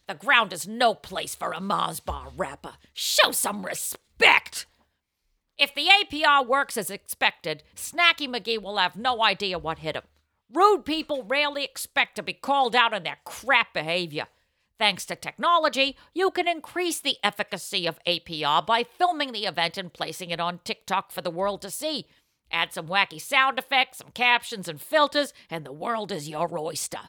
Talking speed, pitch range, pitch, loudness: 175 wpm, 175-280 Hz, 220 Hz, -24 LUFS